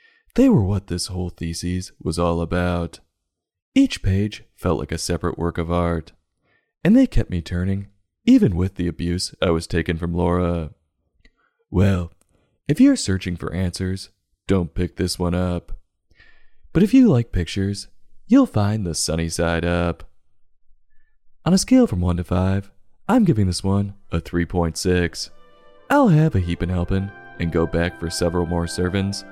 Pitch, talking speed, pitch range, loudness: 90 Hz, 165 wpm, 85-100 Hz, -21 LUFS